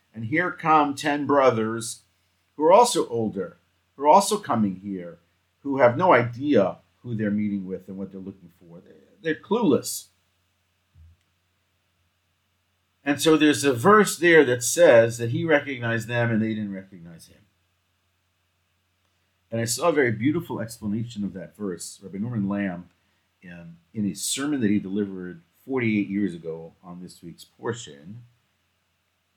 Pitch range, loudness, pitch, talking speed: 90-115 Hz, -22 LUFS, 100 Hz, 150 wpm